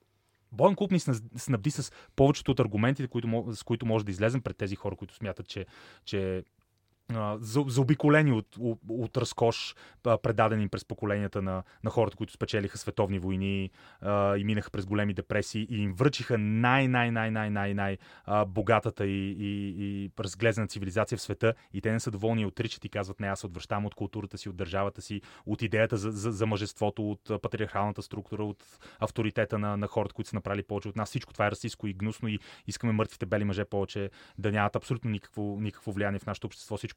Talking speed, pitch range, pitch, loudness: 190 wpm, 100-115 Hz, 105 Hz, -31 LUFS